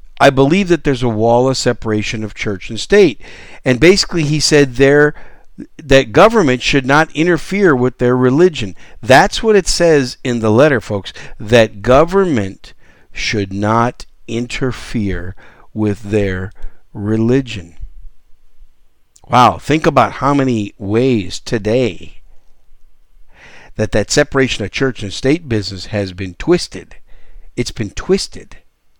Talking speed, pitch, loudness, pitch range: 130 wpm, 115 Hz, -14 LUFS, 100-140 Hz